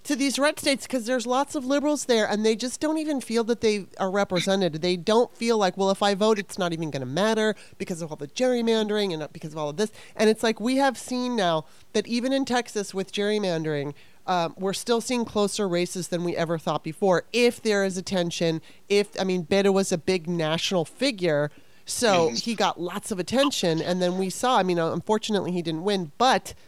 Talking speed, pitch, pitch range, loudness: 225 wpm, 200 Hz, 175-235 Hz, -25 LUFS